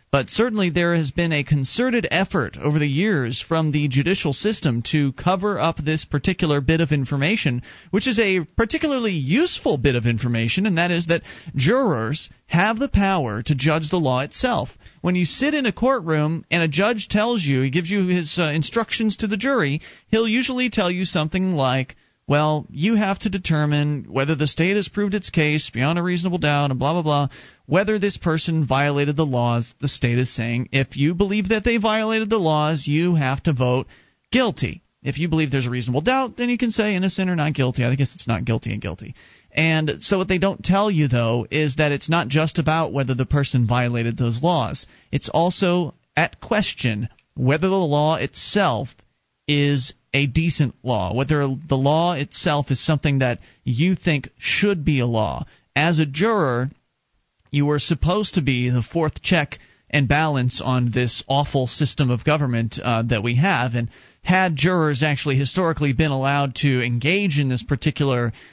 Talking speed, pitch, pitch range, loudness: 190 wpm, 150 Hz, 135-180 Hz, -21 LUFS